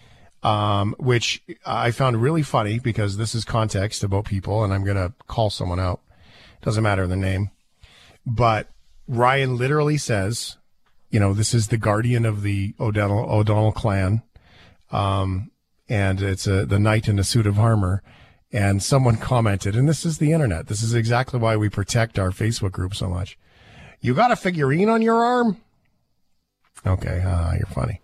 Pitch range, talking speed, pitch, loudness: 100-120 Hz, 165 wpm, 110 Hz, -22 LUFS